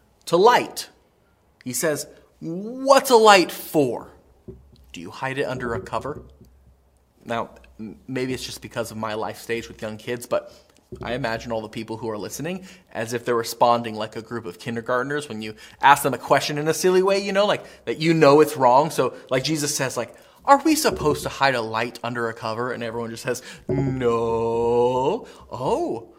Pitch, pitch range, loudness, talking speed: 120 Hz, 115-150 Hz, -22 LUFS, 195 wpm